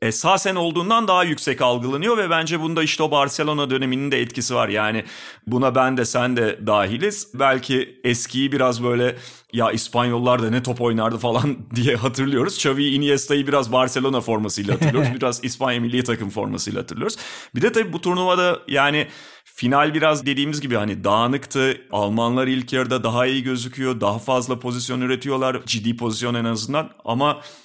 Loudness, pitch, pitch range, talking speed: -20 LUFS, 130 Hz, 120-145 Hz, 160 wpm